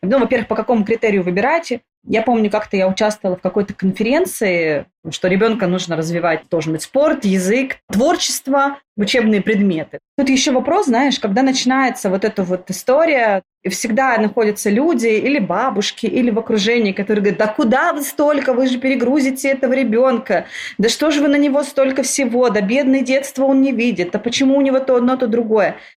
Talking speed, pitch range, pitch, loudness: 175 wpm, 205-265 Hz, 235 Hz, -16 LUFS